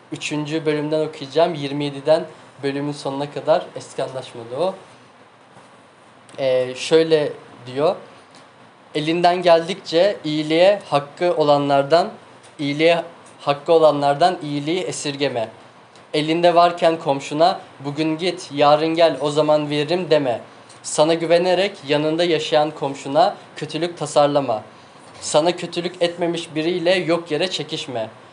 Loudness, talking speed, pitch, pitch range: -19 LUFS, 100 wpm, 155 Hz, 145-170 Hz